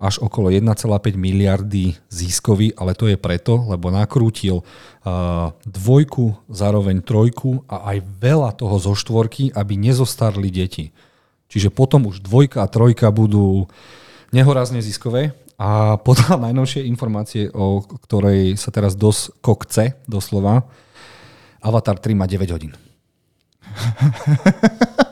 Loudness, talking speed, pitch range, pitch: -17 LUFS, 115 wpm, 100-125 Hz, 110 Hz